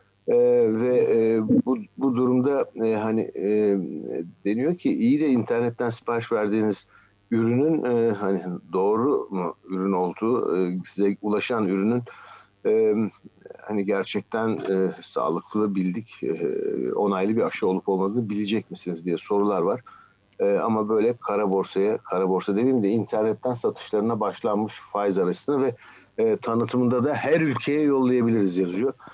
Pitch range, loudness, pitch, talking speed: 100-135 Hz, -24 LUFS, 110 Hz, 135 wpm